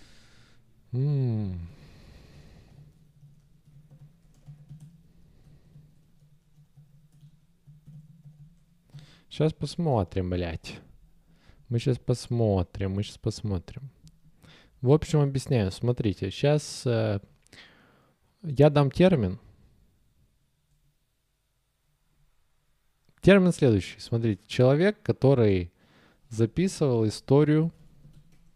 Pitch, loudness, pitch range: 145 Hz, -26 LUFS, 115-150 Hz